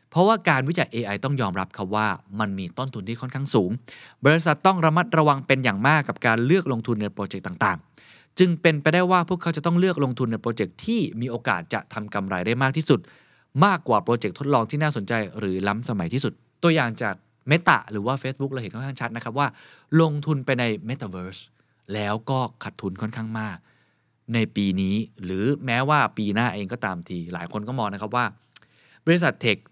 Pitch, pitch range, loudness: 120 Hz, 105-145 Hz, -24 LUFS